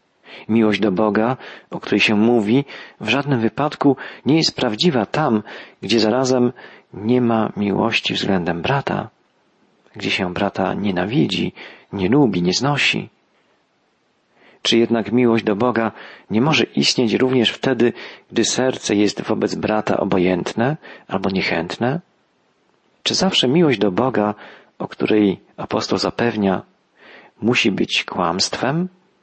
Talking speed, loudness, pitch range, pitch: 120 wpm, -18 LUFS, 105-130 Hz, 115 Hz